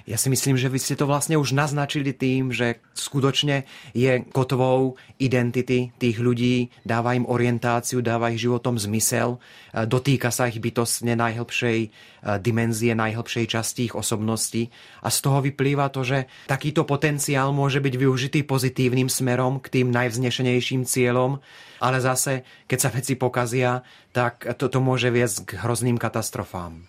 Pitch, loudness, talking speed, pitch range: 125 Hz, -23 LUFS, 145 wpm, 120-135 Hz